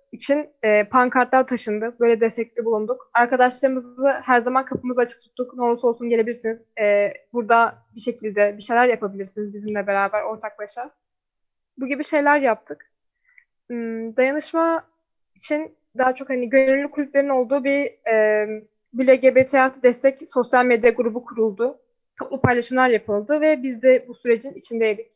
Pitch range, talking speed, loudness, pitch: 225-270 Hz, 135 wpm, -20 LUFS, 245 Hz